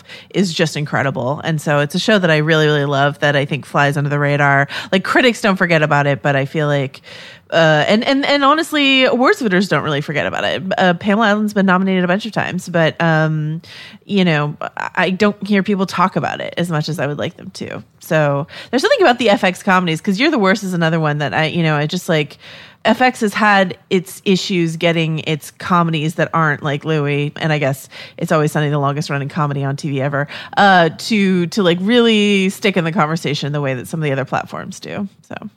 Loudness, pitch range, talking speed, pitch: -16 LUFS, 150-195 Hz, 230 wpm, 165 Hz